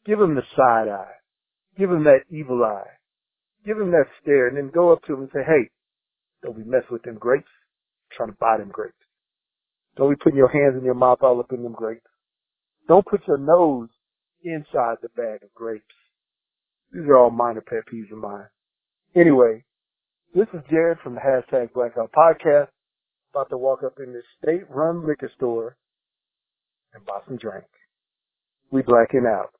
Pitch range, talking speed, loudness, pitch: 120-160 Hz, 185 wpm, -20 LUFS, 135 Hz